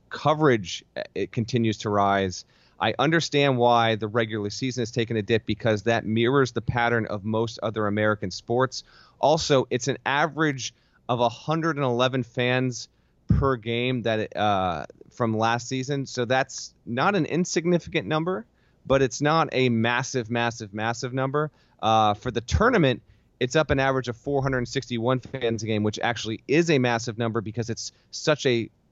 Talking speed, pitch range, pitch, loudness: 160 wpm, 110-135 Hz, 120 Hz, -25 LUFS